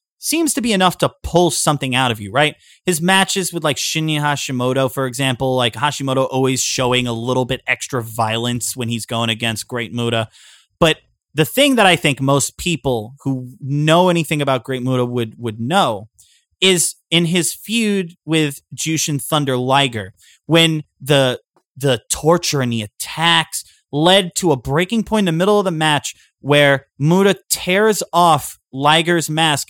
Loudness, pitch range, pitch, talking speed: -17 LUFS, 125-170 Hz, 145 Hz, 170 wpm